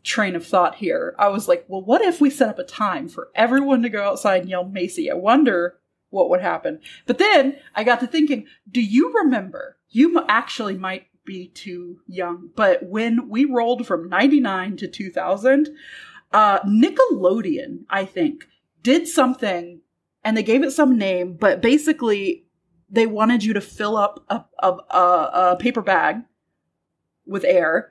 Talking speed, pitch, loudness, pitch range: 170 wpm, 225 Hz, -19 LUFS, 190-275 Hz